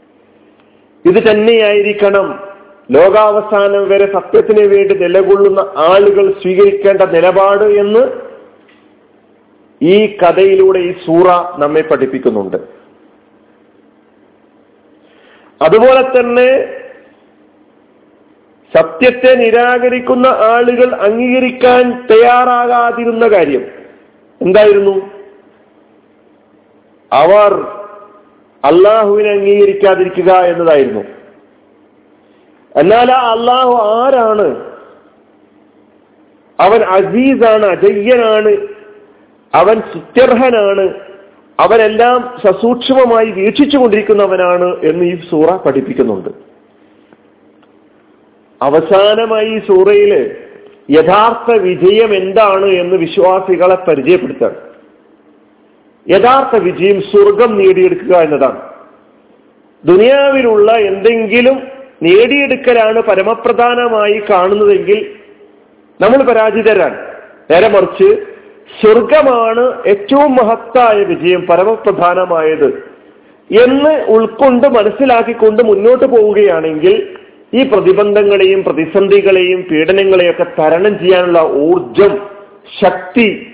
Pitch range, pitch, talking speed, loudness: 195-255 Hz, 220 Hz, 65 wpm, -9 LUFS